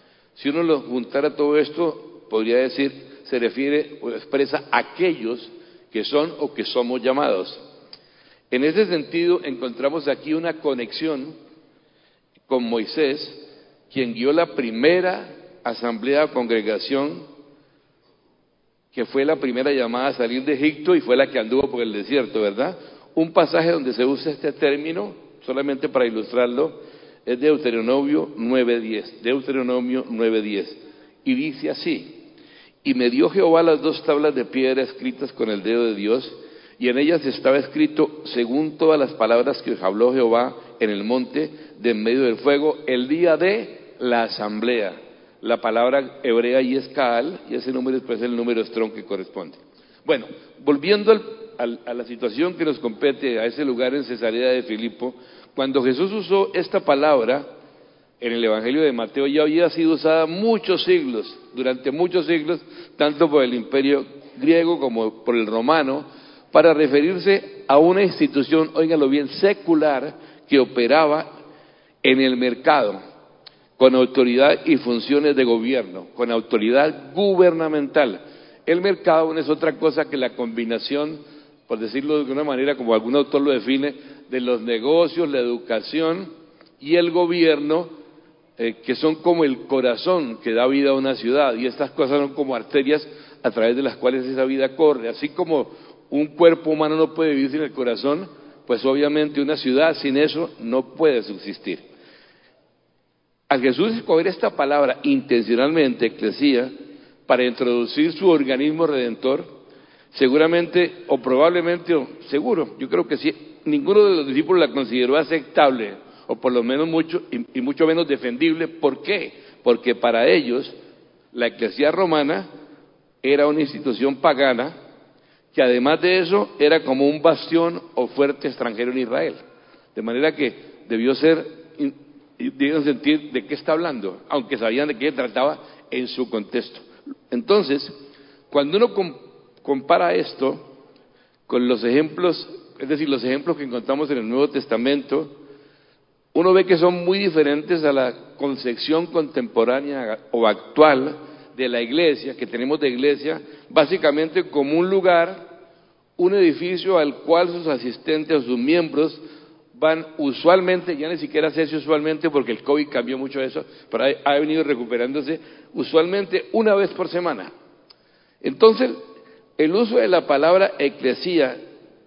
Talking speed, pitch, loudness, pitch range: 150 wpm, 145 Hz, -20 LUFS, 130-160 Hz